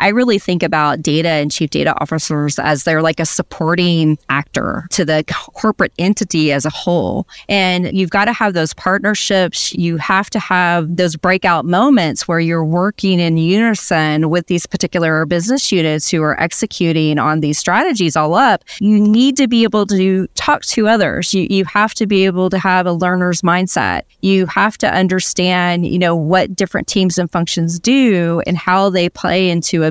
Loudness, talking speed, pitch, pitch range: -14 LUFS, 185 wpm, 180 Hz, 165-195 Hz